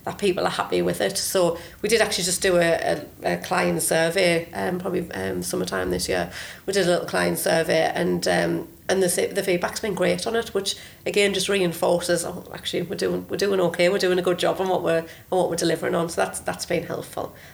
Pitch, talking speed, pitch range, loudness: 175 Hz, 235 wpm, 165-190 Hz, -23 LUFS